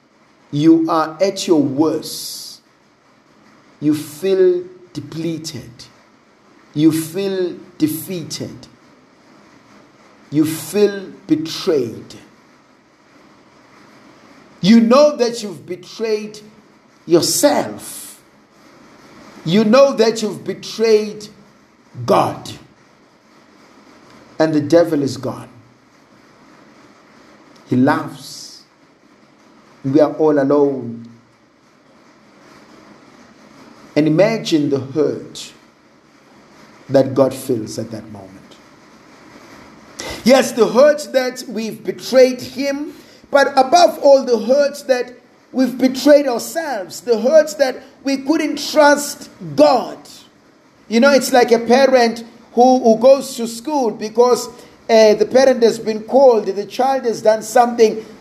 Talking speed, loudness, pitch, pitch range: 95 wpm, -15 LUFS, 220 Hz, 160-260 Hz